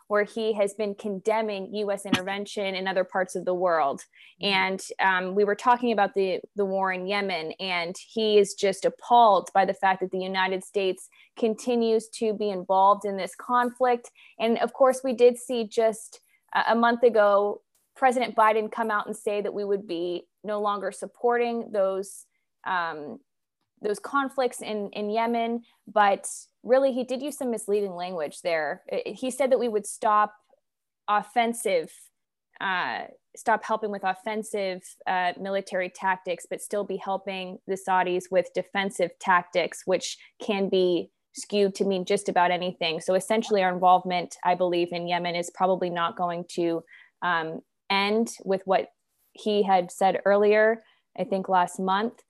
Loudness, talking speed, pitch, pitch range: -26 LUFS, 160 wpm, 200 Hz, 185-225 Hz